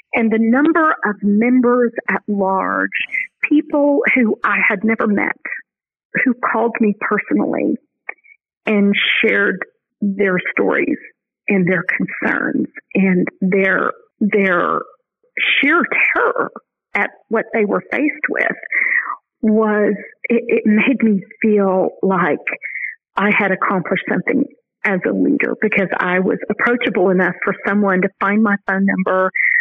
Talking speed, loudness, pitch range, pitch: 125 wpm, -16 LUFS, 200-275 Hz, 215 Hz